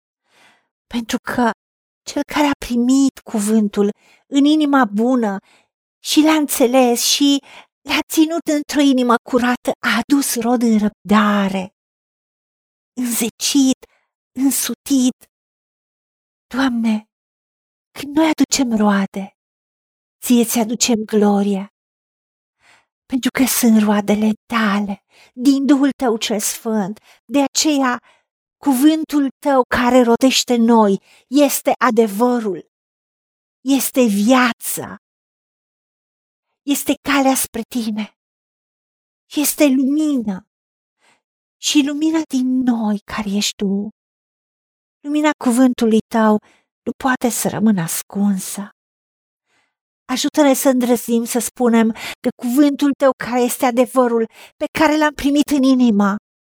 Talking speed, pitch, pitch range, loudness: 100 wpm, 245 Hz, 220-275 Hz, -17 LUFS